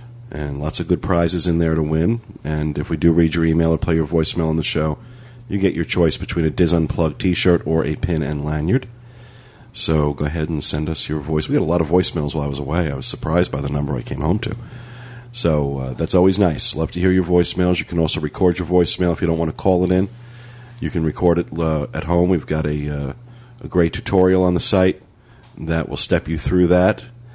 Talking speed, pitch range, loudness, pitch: 245 wpm, 80-95 Hz, -19 LUFS, 85 Hz